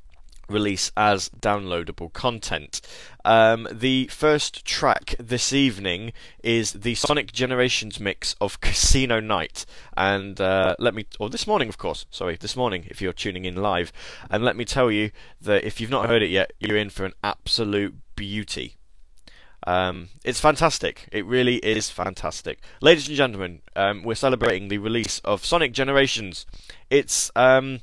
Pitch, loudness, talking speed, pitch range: 105 Hz, -23 LUFS, 155 wpm, 95-125 Hz